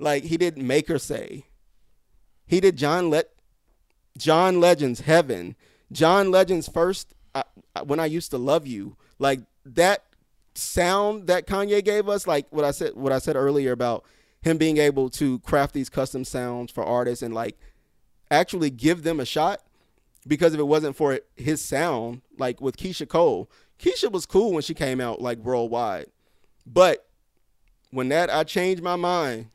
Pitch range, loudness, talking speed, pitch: 130-175 Hz, -23 LUFS, 170 wpm, 155 Hz